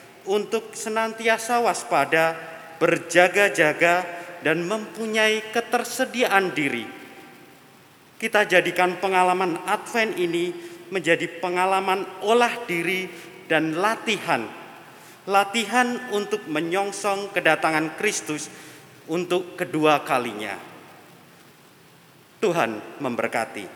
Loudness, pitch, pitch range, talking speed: -23 LUFS, 180 Hz, 170-215 Hz, 75 wpm